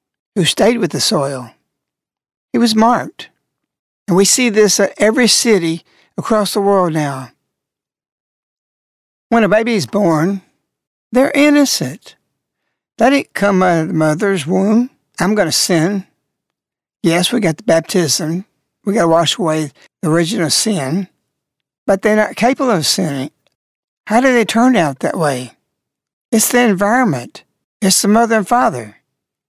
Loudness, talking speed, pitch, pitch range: -14 LUFS, 145 wpm, 200 Hz, 170-230 Hz